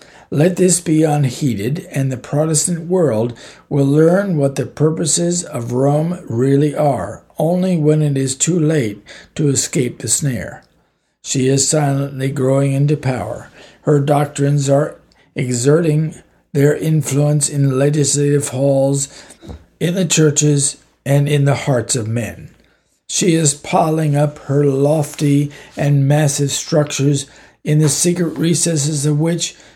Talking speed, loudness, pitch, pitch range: 135 wpm, -16 LUFS, 145 Hz, 140-155 Hz